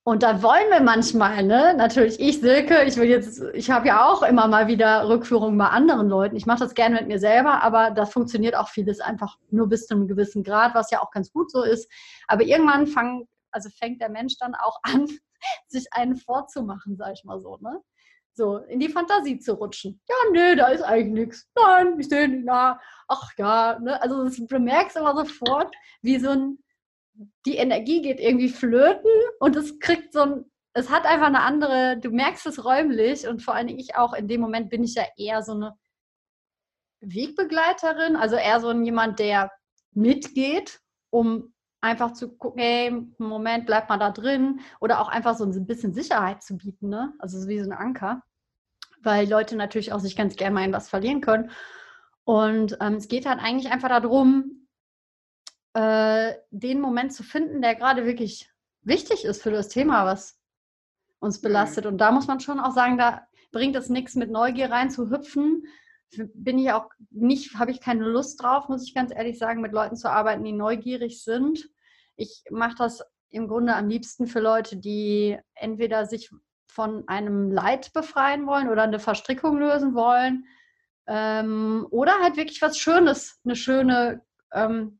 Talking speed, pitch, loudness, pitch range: 190 wpm, 240 Hz, -22 LUFS, 220-275 Hz